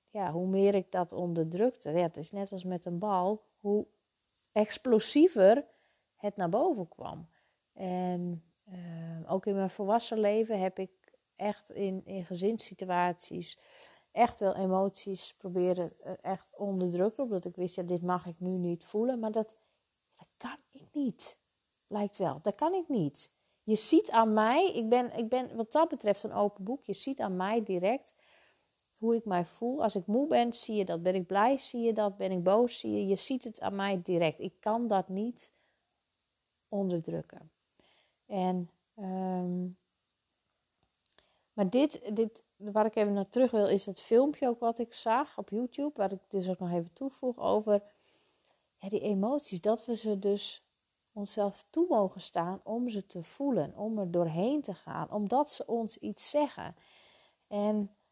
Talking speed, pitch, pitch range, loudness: 175 wpm, 205 Hz, 185-230 Hz, -32 LUFS